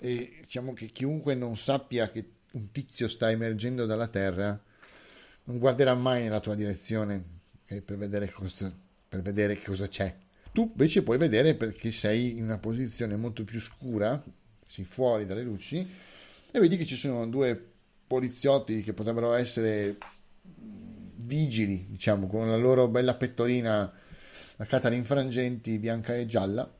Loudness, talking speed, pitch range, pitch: -29 LUFS, 150 wpm, 105-125 Hz, 115 Hz